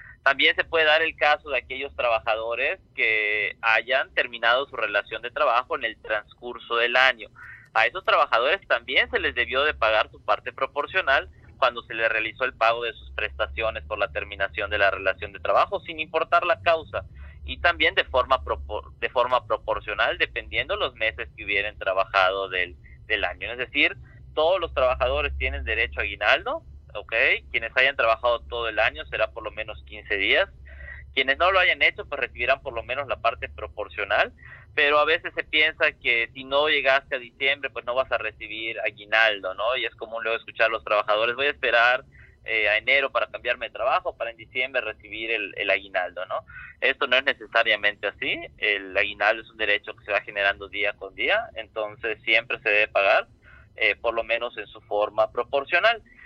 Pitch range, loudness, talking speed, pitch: 105-145 Hz, -23 LUFS, 190 wpm, 115 Hz